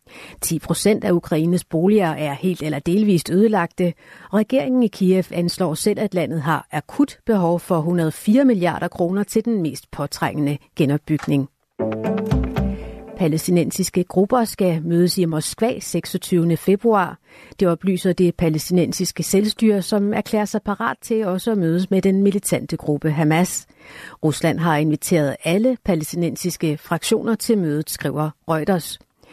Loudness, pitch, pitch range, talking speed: -20 LUFS, 175 Hz, 155-200 Hz, 135 wpm